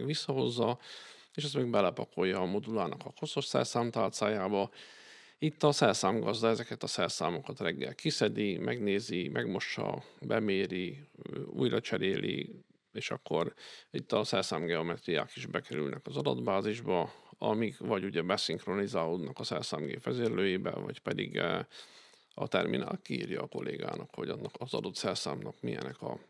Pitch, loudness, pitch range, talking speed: 115 Hz, -34 LUFS, 95-140 Hz, 120 wpm